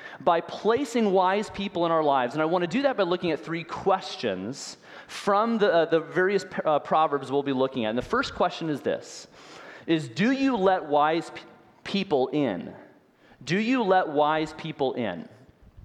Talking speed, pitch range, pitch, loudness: 185 wpm, 150-195 Hz, 170 Hz, -25 LUFS